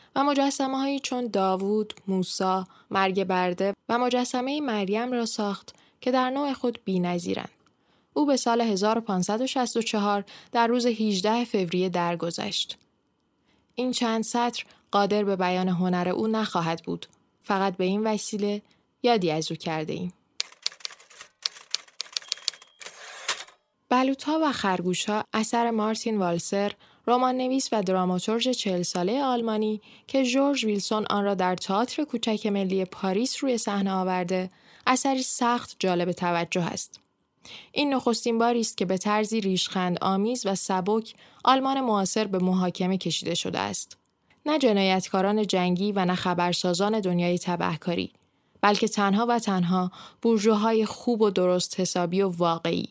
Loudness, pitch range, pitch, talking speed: -26 LUFS, 185-235 Hz, 205 Hz, 130 wpm